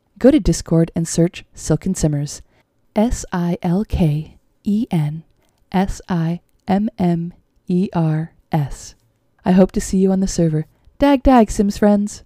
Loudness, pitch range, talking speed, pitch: -18 LUFS, 160-200 Hz, 155 wpm, 175 Hz